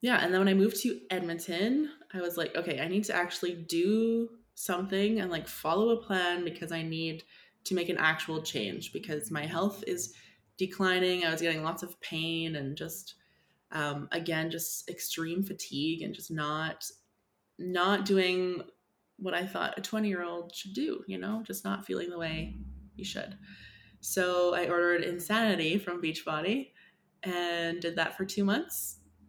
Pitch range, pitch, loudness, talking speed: 160-195 Hz, 175 Hz, -32 LUFS, 170 wpm